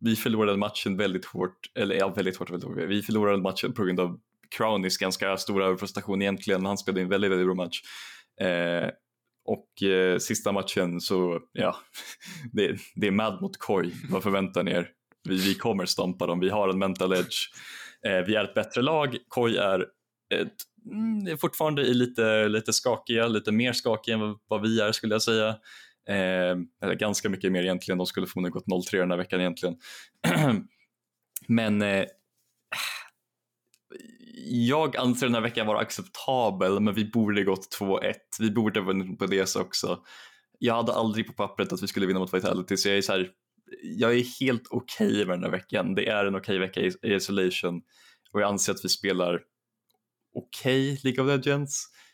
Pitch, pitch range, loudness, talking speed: 100 Hz, 95-110 Hz, -27 LUFS, 185 wpm